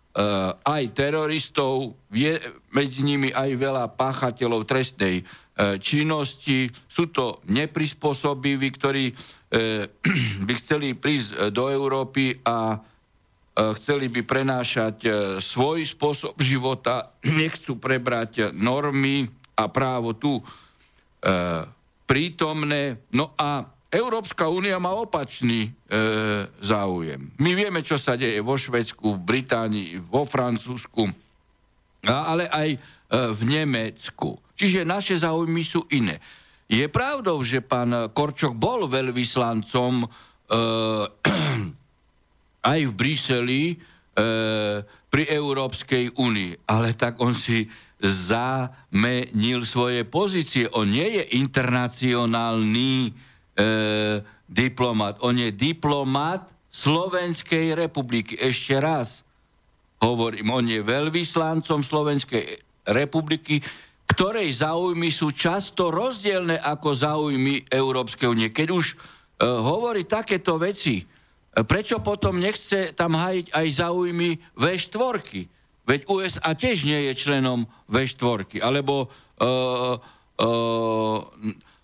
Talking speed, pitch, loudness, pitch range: 100 wpm, 130 Hz, -24 LUFS, 115-150 Hz